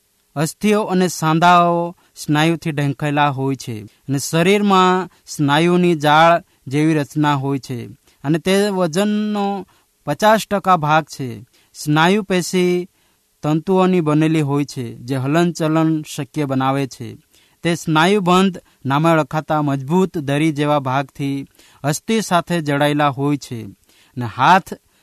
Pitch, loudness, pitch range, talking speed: 155 Hz, -17 LUFS, 140-180 Hz, 115 wpm